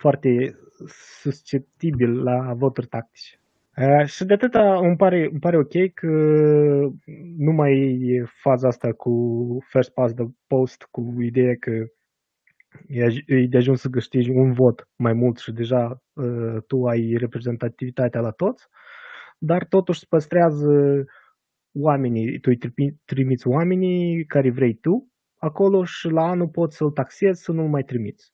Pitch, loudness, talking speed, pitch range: 135 Hz, -21 LUFS, 150 wpm, 125-165 Hz